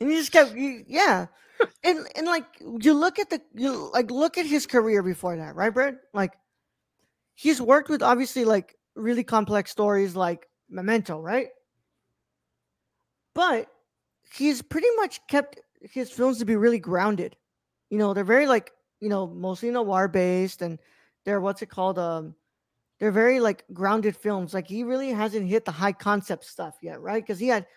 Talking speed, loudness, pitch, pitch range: 175 wpm, -25 LUFS, 225 Hz, 195-265 Hz